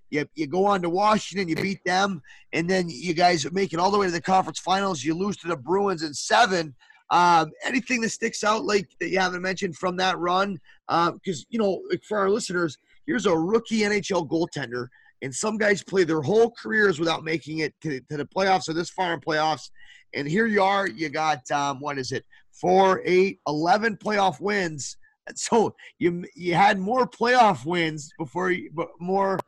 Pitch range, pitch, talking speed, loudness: 160-200 Hz, 185 Hz, 200 wpm, -24 LUFS